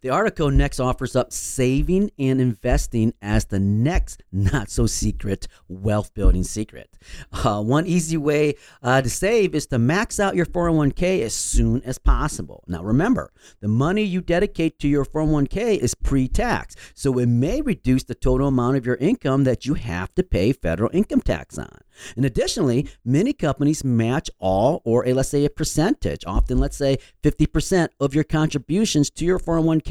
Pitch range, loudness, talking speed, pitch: 115-155 Hz, -21 LUFS, 175 wpm, 135 Hz